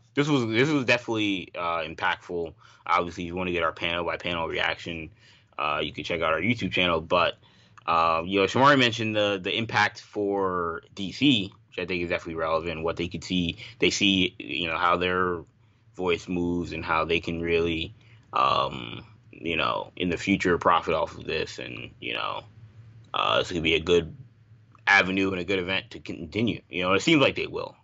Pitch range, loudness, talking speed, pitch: 85-115 Hz, -25 LUFS, 200 wpm, 95 Hz